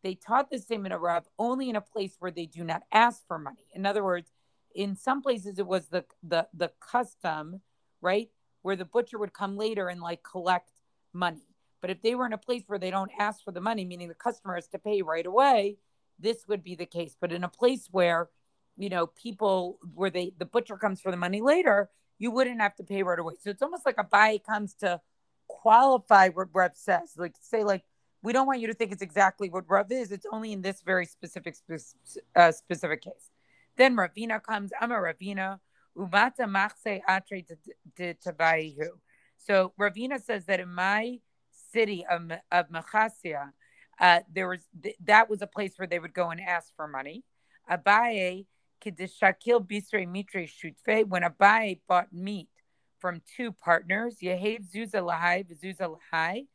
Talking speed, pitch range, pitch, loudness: 185 wpm, 175-215 Hz, 195 Hz, -28 LUFS